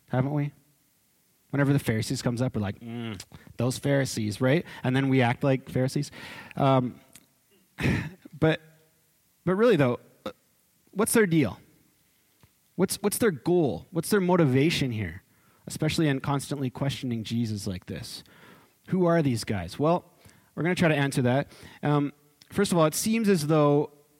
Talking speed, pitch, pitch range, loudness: 150 wpm, 140 Hz, 125-160 Hz, -26 LUFS